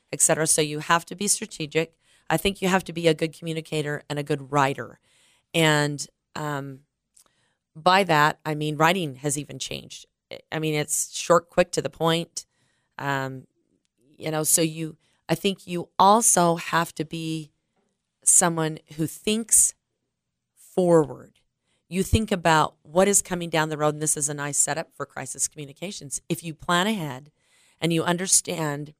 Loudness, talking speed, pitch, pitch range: -23 LUFS, 165 wpm, 160 Hz, 150-170 Hz